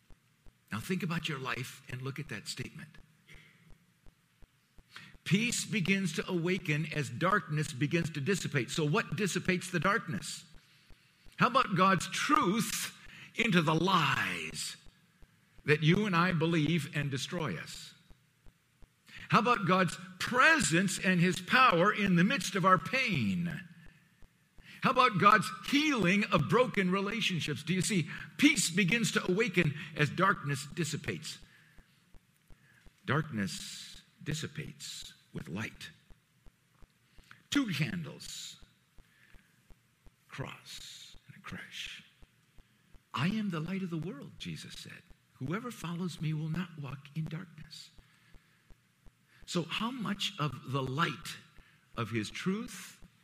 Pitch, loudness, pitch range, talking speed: 170 Hz, -31 LUFS, 155-190 Hz, 120 wpm